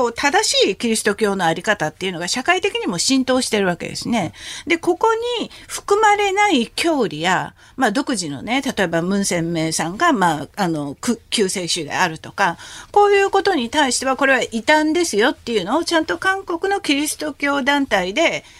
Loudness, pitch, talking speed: -18 LUFS, 265 Hz, 370 characters per minute